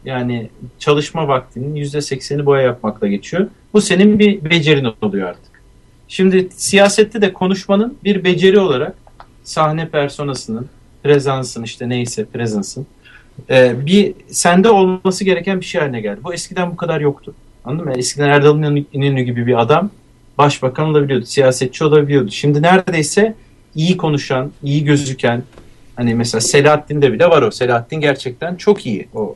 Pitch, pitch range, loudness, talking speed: 145 Hz, 125-175 Hz, -15 LUFS, 140 wpm